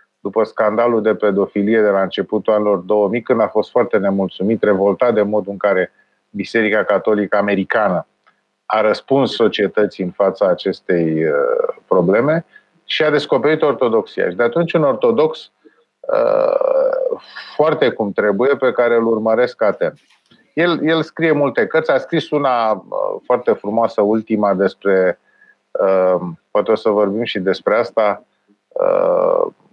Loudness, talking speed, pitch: -16 LUFS, 140 wpm, 115 Hz